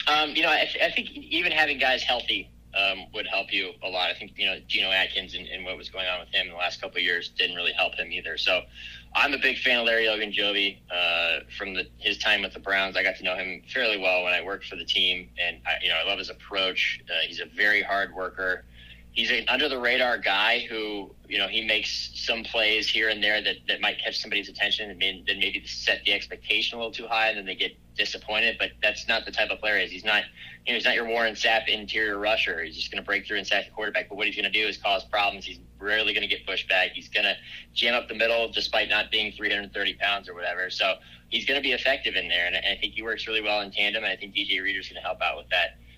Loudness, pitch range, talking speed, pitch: -25 LUFS, 95-115 Hz, 275 wpm, 105 Hz